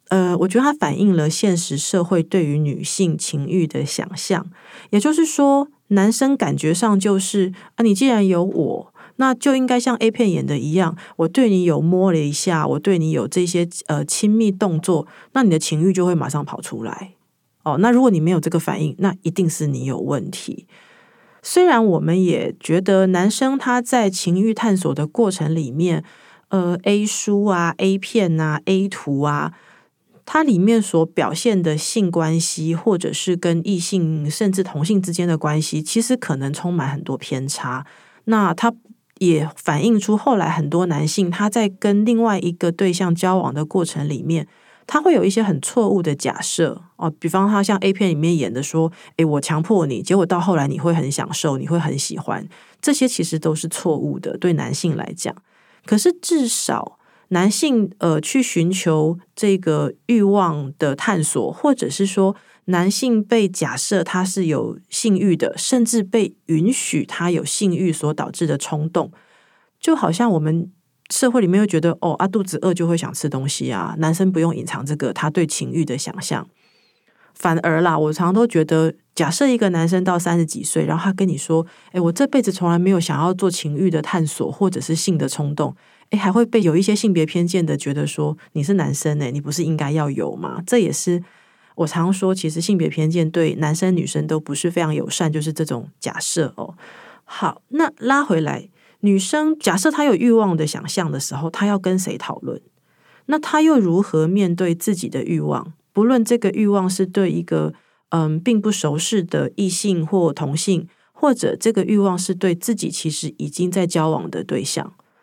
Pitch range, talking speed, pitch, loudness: 160-205 Hz, 270 characters per minute, 180 Hz, -19 LUFS